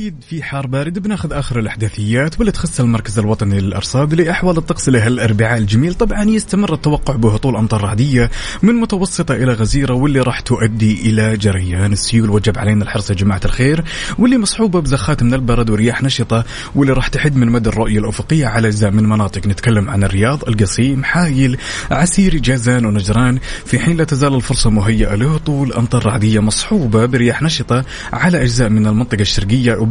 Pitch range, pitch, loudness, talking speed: 110-145 Hz, 120 Hz, -14 LUFS, 165 wpm